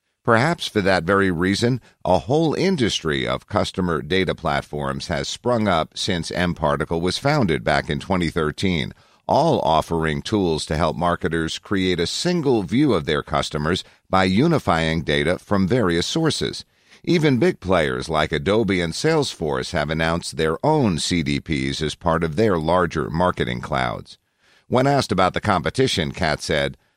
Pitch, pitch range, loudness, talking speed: 90 Hz, 75-115 Hz, -21 LUFS, 150 wpm